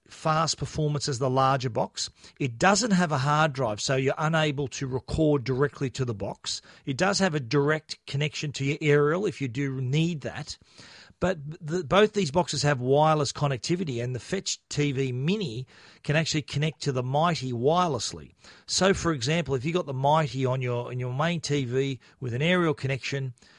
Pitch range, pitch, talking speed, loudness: 135-160 Hz, 145 Hz, 185 wpm, -26 LUFS